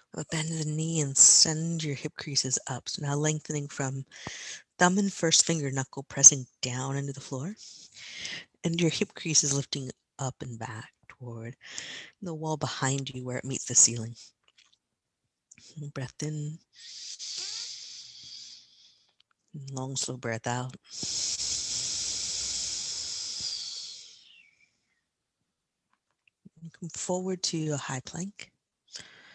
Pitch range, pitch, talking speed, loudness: 130-160 Hz, 140 Hz, 115 wpm, -27 LUFS